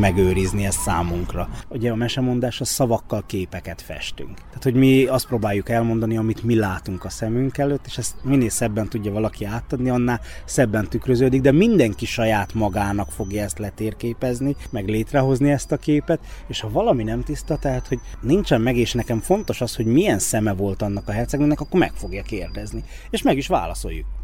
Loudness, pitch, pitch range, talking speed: -21 LUFS, 115 Hz, 105-130 Hz, 180 wpm